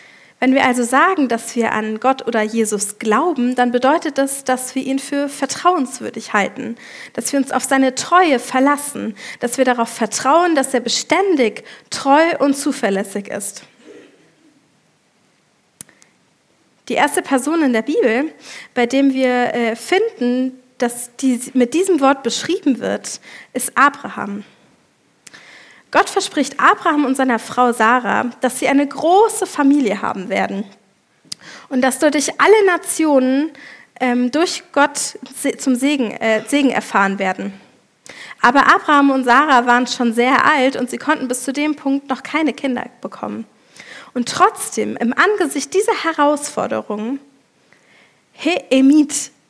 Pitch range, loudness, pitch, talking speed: 245-290 Hz, -16 LUFS, 265 Hz, 135 wpm